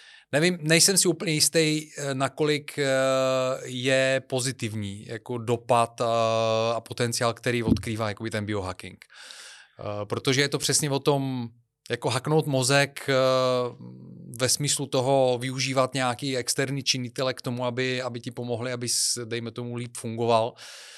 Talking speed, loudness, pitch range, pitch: 125 wpm, -25 LUFS, 115-140 Hz, 130 Hz